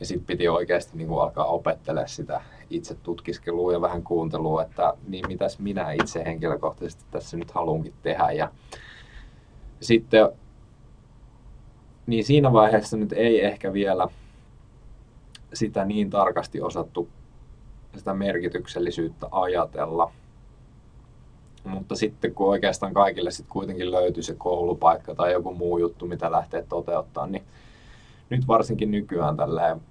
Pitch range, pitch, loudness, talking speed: 90-115 Hz, 100 Hz, -25 LUFS, 120 wpm